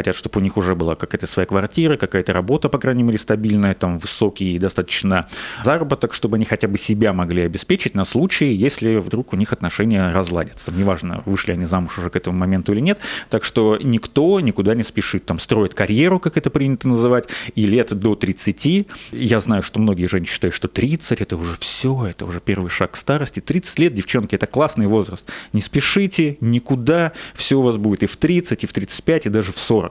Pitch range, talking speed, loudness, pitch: 95-125 Hz, 205 wpm, -19 LUFS, 110 Hz